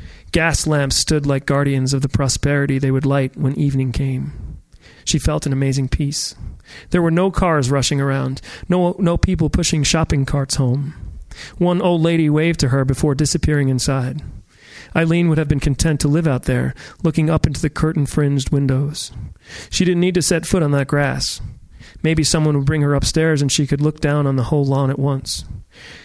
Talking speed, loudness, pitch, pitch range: 190 wpm, -18 LUFS, 145 Hz, 135-155 Hz